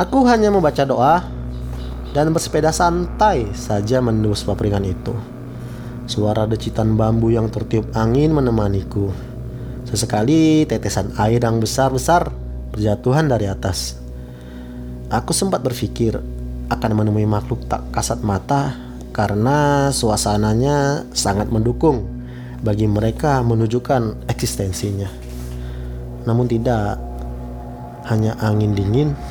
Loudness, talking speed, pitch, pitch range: -18 LUFS, 100 wpm, 110 Hz, 95-125 Hz